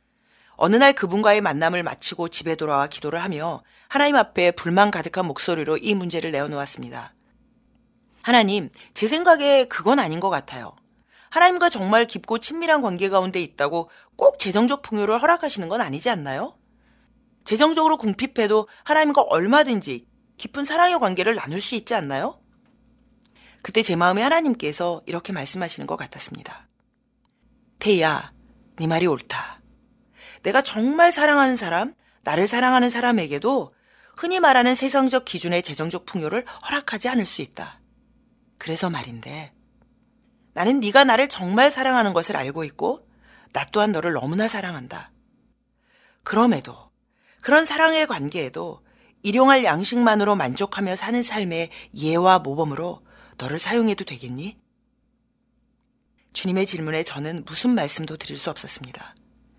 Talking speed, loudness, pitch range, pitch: 315 characters per minute, -19 LUFS, 175-245 Hz, 225 Hz